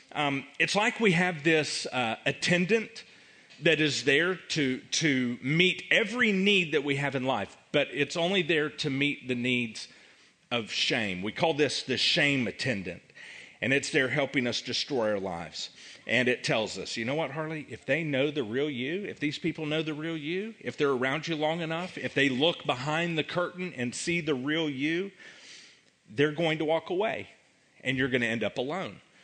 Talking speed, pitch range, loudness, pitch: 195 wpm, 140-170 Hz, -28 LUFS, 155 Hz